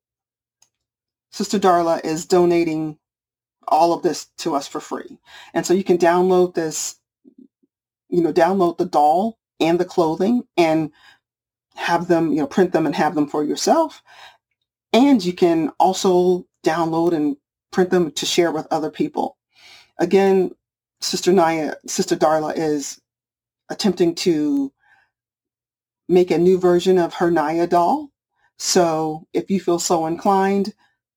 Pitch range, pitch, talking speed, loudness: 160-195 Hz, 175 Hz, 140 wpm, -19 LUFS